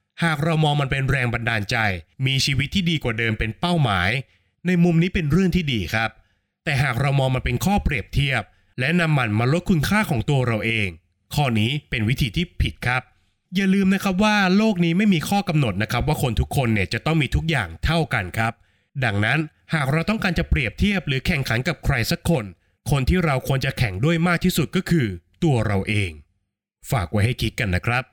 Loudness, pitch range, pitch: -21 LUFS, 110-165 Hz, 135 Hz